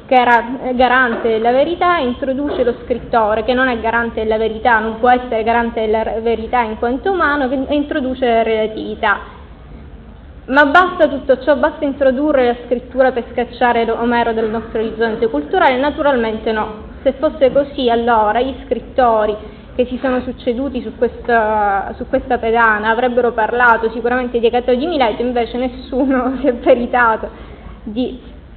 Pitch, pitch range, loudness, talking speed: 245 Hz, 225-260 Hz, -15 LUFS, 150 wpm